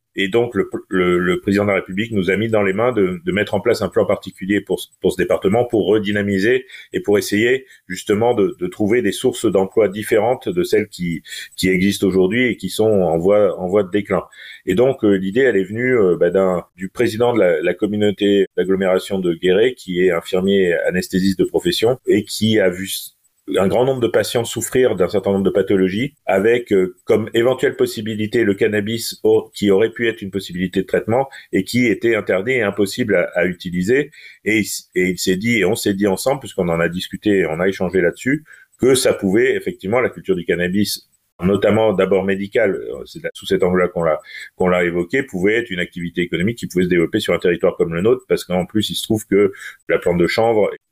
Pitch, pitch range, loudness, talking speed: 100 Hz, 95-120 Hz, -18 LUFS, 220 wpm